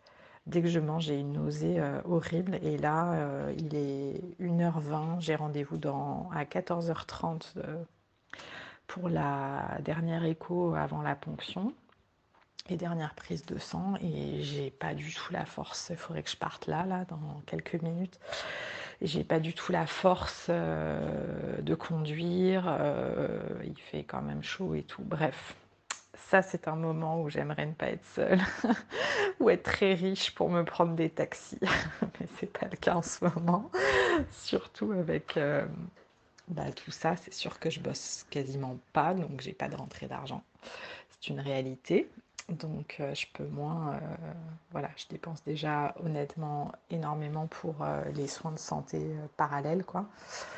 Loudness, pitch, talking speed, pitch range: -33 LUFS, 160 Hz, 165 wpm, 145-175 Hz